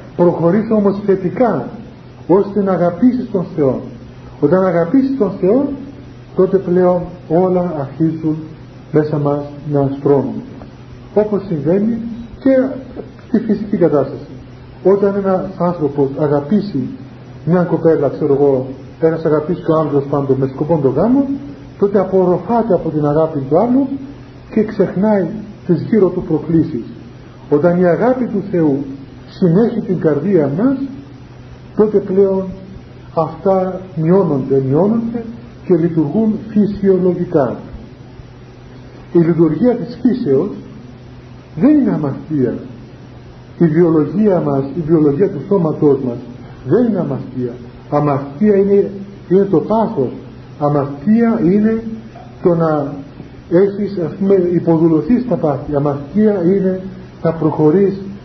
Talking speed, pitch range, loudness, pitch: 115 wpm, 140-195 Hz, -15 LUFS, 170 Hz